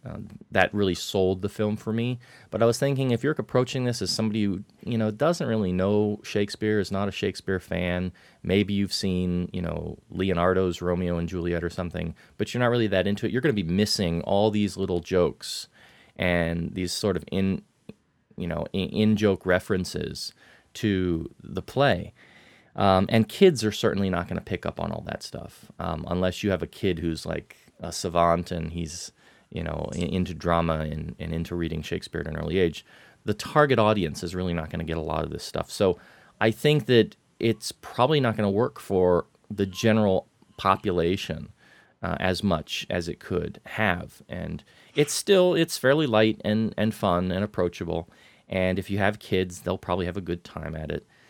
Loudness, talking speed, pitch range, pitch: -26 LUFS, 195 wpm, 90-110 Hz, 95 Hz